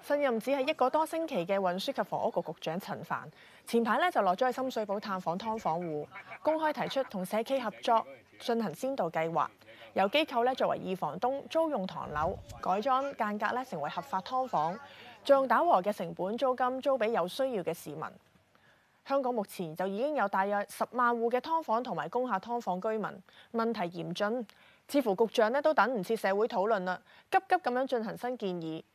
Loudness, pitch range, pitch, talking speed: -32 LUFS, 190-260 Hz, 230 Hz, 295 characters per minute